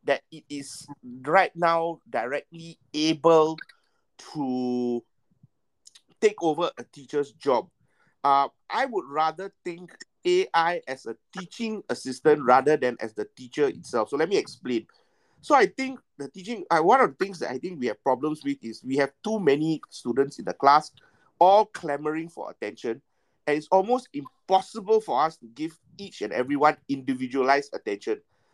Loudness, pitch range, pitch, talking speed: -25 LUFS, 140-200 Hz, 155 Hz, 160 wpm